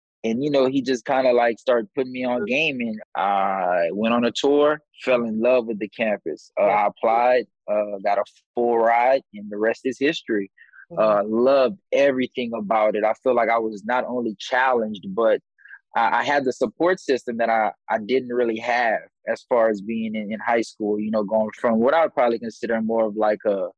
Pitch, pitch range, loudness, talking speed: 115 Hz, 110-125 Hz, -22 LUFS, 215 wpm